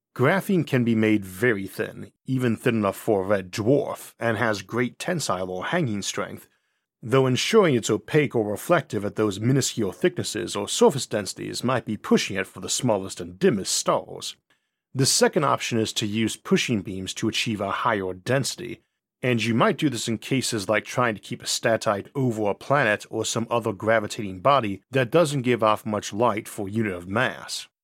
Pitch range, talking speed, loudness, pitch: 105-130 Hz, 190 wpm, -24 LUFS, 115 Hz